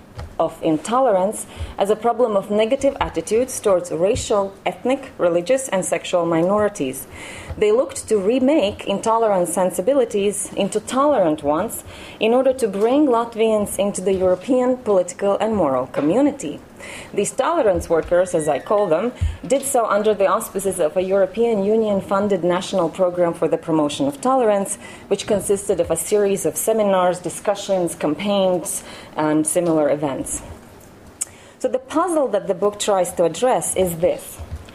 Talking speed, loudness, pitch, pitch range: 145 wpm, -19 LUFS, 195 Hz, 170-225 Hz